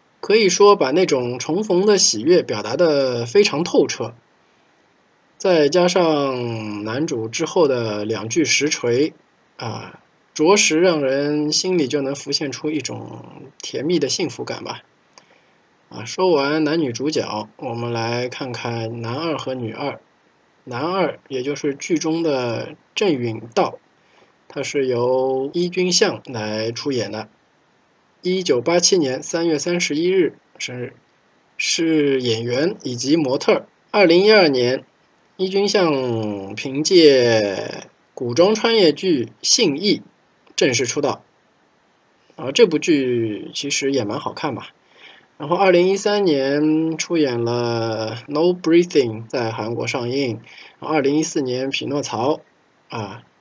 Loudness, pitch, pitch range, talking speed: -19 LUFS, 140 Hz, 120-170 Hz, 200 characters per minute